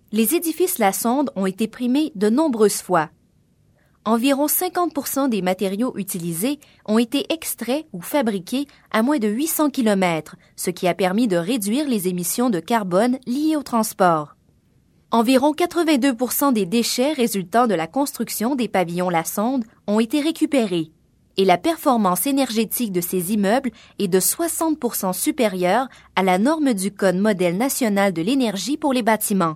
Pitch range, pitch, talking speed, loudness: 190-275 Hz, 230 Hz, 155 wpm, -20 LUFS